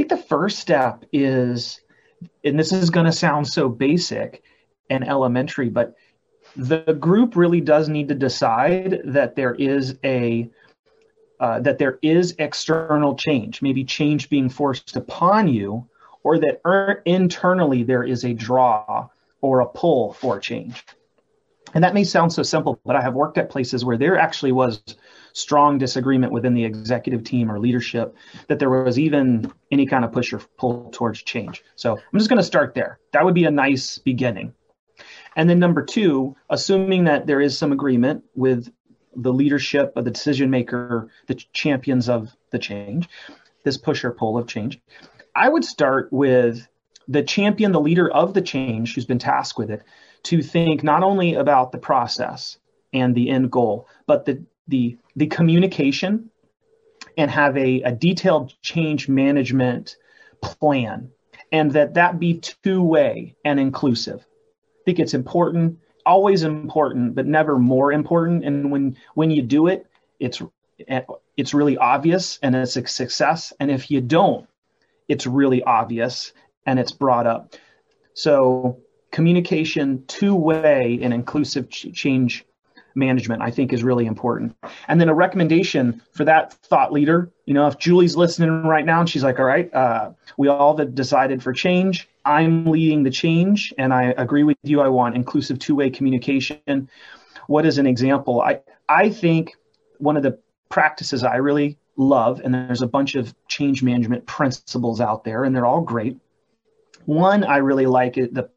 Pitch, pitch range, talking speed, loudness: 140 Hz, 125-165 Hz, 165 wpm, -19 LUFS